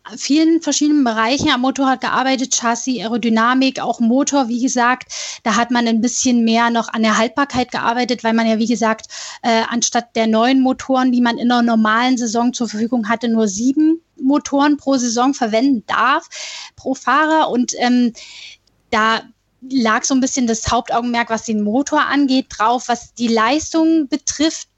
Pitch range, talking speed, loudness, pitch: 230-270 Hz, 170 wpm, -16 LUFS, 245 Hz